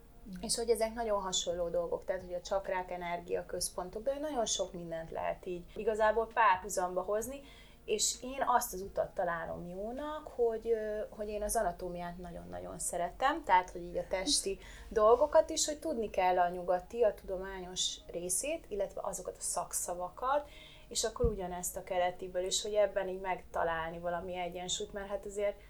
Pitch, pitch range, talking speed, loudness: 200 Hz, 180-235 Hz, 160 wpm, -34 LUFS